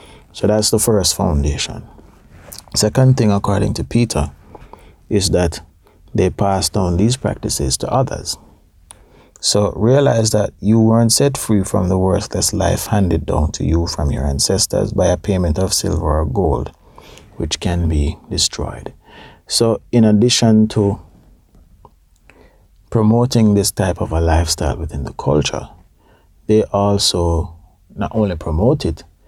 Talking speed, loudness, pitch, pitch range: 135 wpm, -16 LUFS, 100 Hz, 85-110 Hz